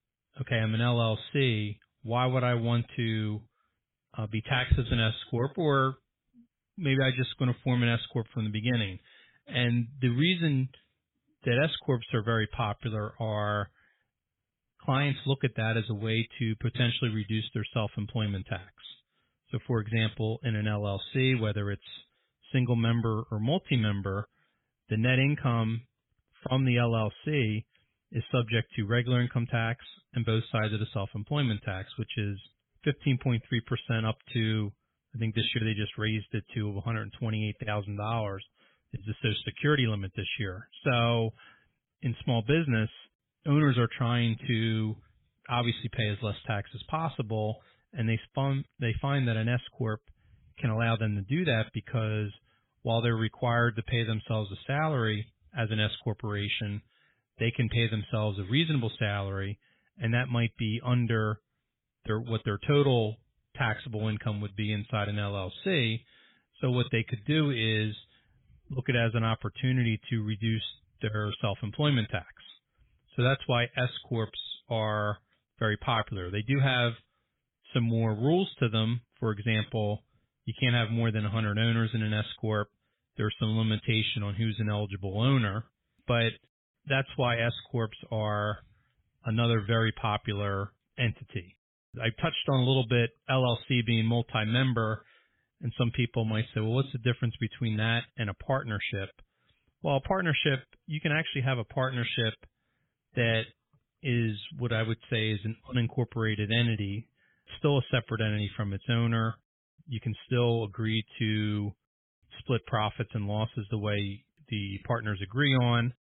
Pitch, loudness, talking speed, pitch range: 115 Hz, -30 LUFS, 155 wpm, 110-125 Hz